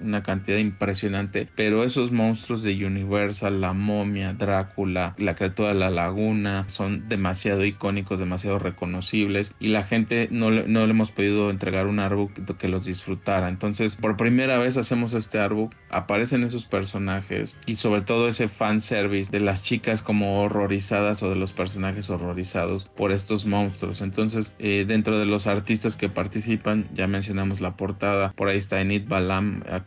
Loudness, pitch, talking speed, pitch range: -25 LUFS, 100 Hz, 165 wpm, 95-110 Hz